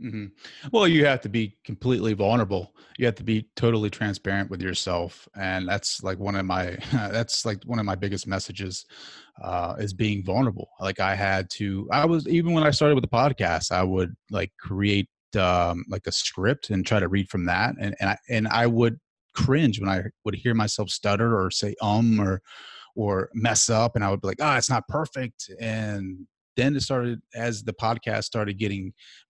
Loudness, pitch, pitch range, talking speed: -25 LUFS, 105 Hz, 95-120 Hz, 205 wpm